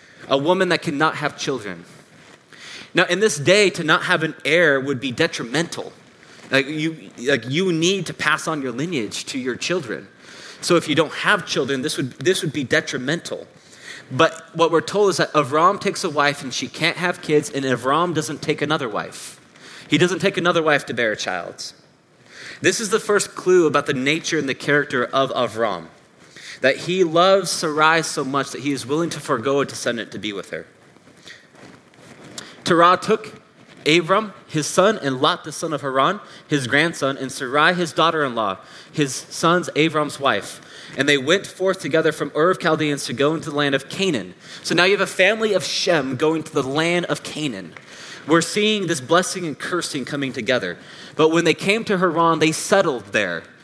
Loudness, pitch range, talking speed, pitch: -20 LUFS, 145-175 Hz, 195 wpm, 160 Hz